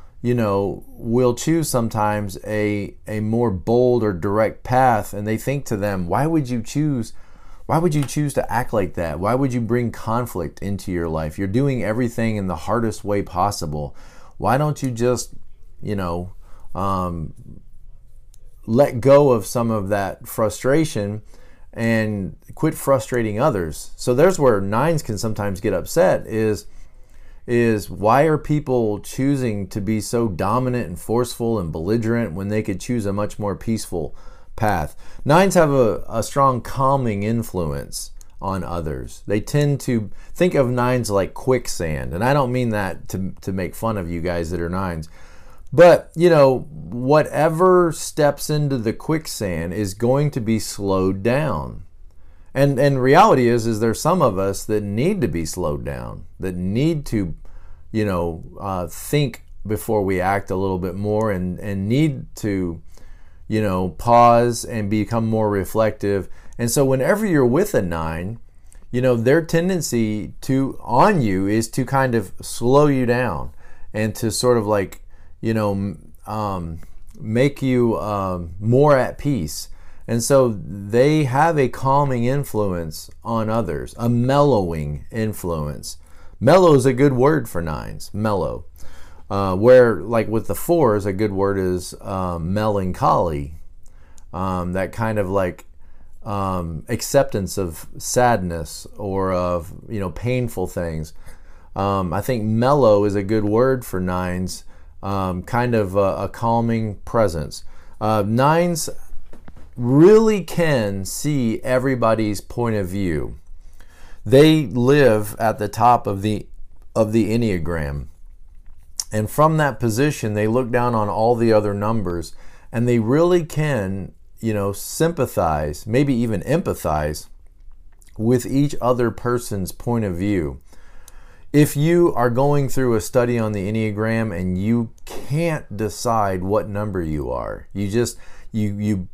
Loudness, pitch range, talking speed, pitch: -20 LUFS, 90-125 Hz, 150 wpm, 105 Hz